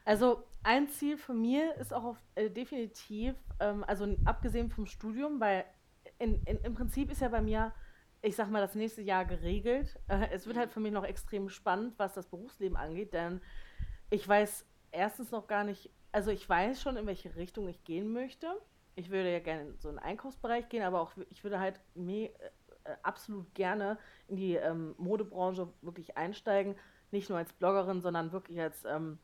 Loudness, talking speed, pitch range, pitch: -36 LUFS, 185 wpm, 185-230 Hz, 205 Hz